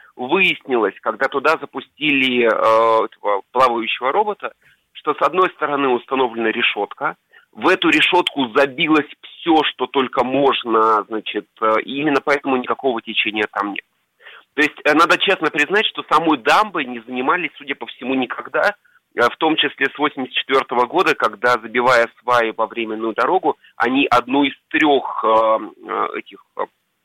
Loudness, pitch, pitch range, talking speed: -17 LUFS, 130 Hz, 115-140 Hz, 145 wpm